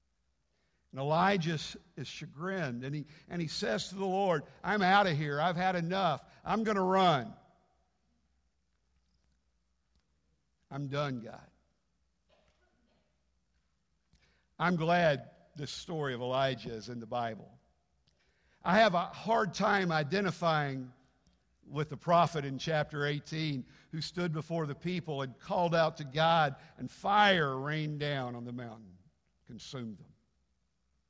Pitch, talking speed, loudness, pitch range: 145 Hz, 130 wpm, -32 LUFS, 115-175 Hz